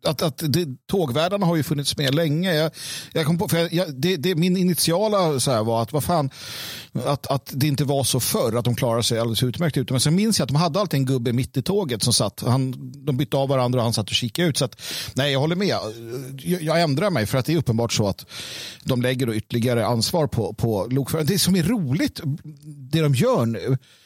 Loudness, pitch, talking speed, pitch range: -22 LUFS, 140 Hz, 245 wpm, 125-165 Hz